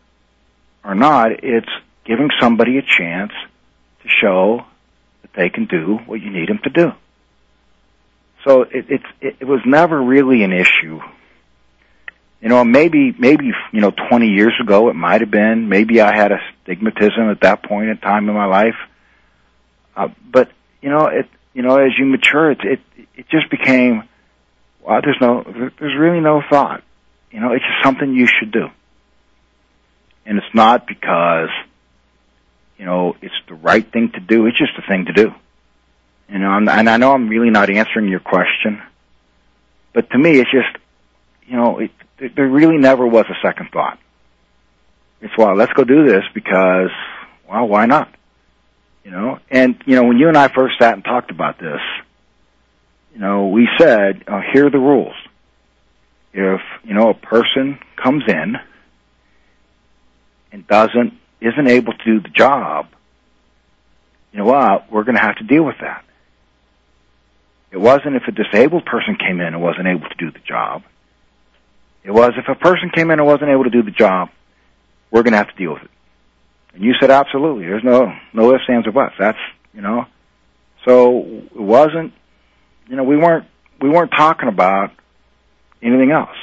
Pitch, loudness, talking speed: 110 Hz, -14 LUFS, 175 wpm